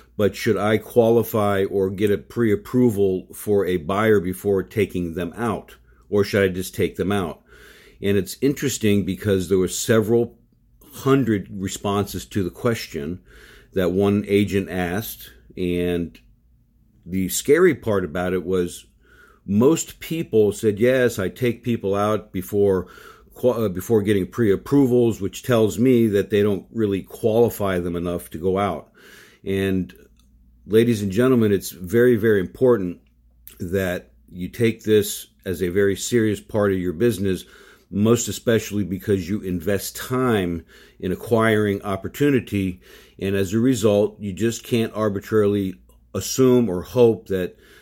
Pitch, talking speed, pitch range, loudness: 100 Hz, 140 wpm, 95-115 Hz, -21 LUFS